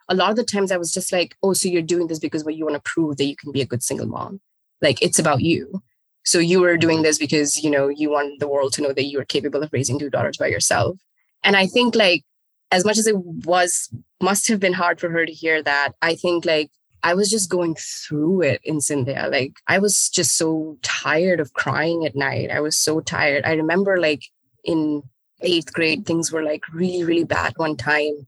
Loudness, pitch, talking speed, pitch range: -20 LUFS, 160 Hz, 240 wpm, 145-180 Hz